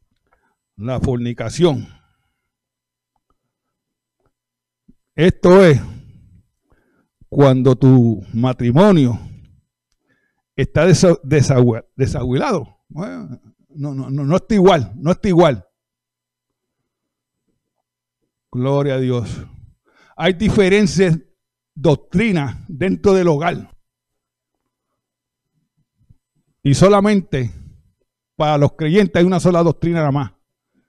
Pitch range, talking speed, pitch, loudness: 125-175 Hz, 75 wpm, 140 Hz, -15 LUFS